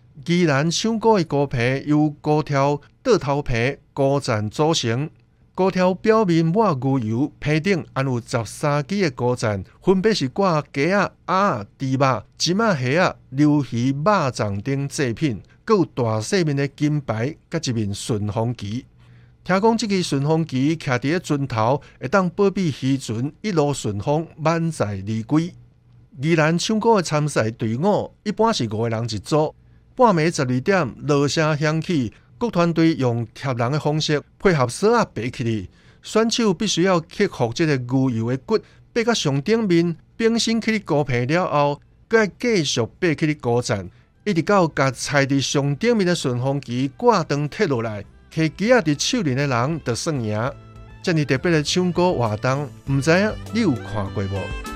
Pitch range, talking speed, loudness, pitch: 120-170 Hz, 235 characters per minute, -21 LUFS, 145 Hz